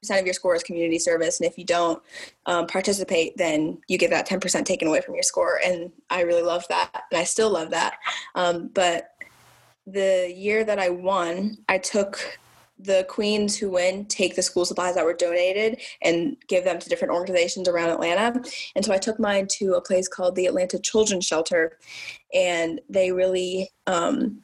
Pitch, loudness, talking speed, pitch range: 185 Hz, -23 LUFS, 190 wpm, 175-205 Hz